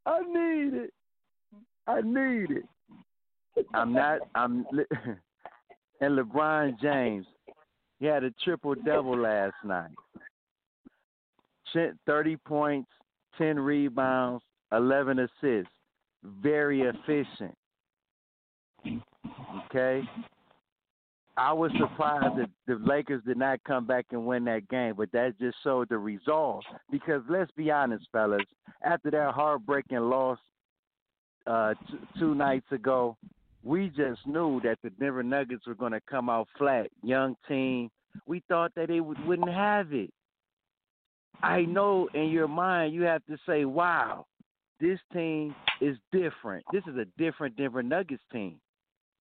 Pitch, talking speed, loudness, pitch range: 140 Hz, 130 wpm, -29 LUFS, 125-165 Hz